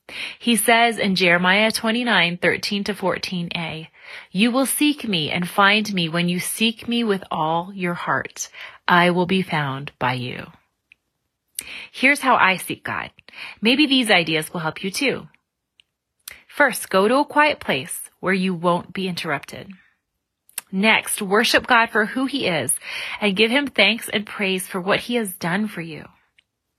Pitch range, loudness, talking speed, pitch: 175-230 Hz, -19 LUFS, 165 wpm, 195 Hz